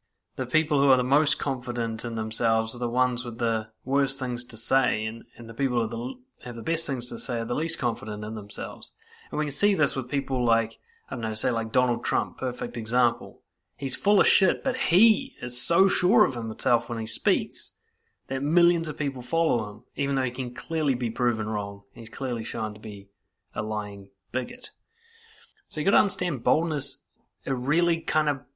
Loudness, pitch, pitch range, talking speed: -26 LUFS, 125 Hz, 115-145 Hz, 205 wpm